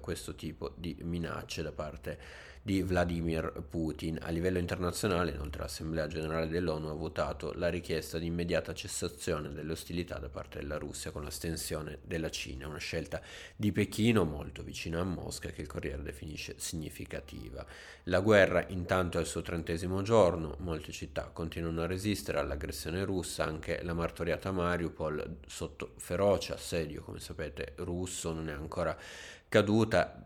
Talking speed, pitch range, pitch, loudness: 150 wpm, 80-90 Hz, 85 Hz, -34 LUFS